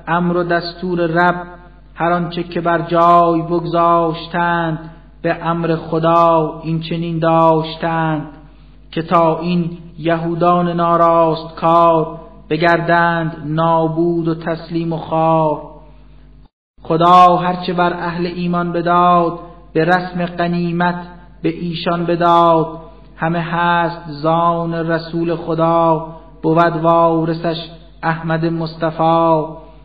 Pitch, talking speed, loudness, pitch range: 170 Hz, 100 wpm, -15 LUFS, 165-170 Hz